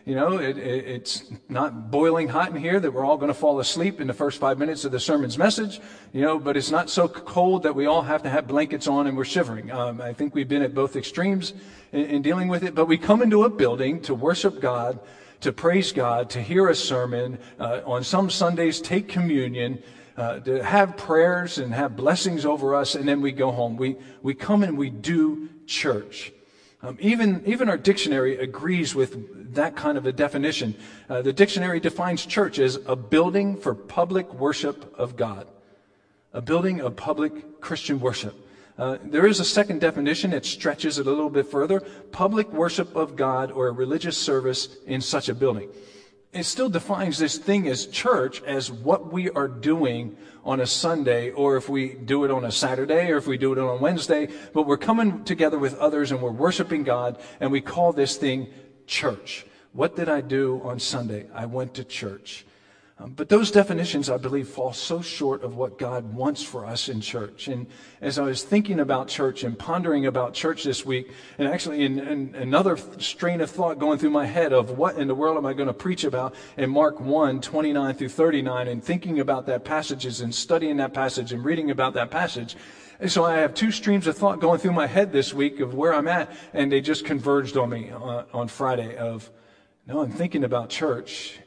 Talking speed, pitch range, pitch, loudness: 210 wpm, 125-160 Hz, 140 Hz, -24 LUFS